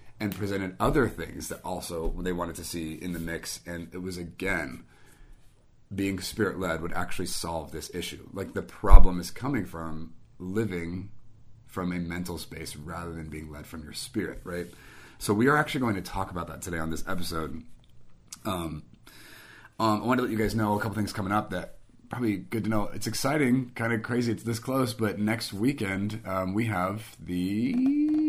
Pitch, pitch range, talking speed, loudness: 95 Hz, 85-110 Hz, 195 wpm, -30 LUFS